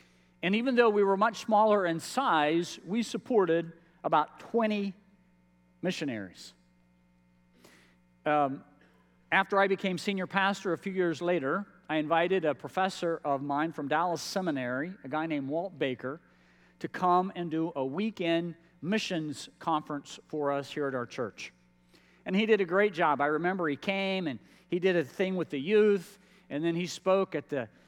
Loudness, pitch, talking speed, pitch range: -30 LUFS, 170 Hz, 165 wpm, 140-195 Hz